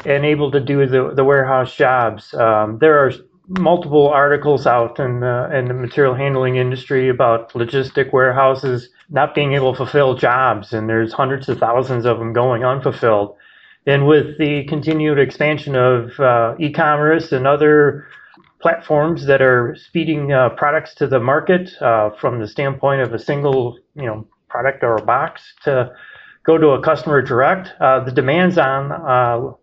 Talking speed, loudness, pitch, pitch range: 165 wpm, -16 LUFS, 135 Hz, 125-150 Hz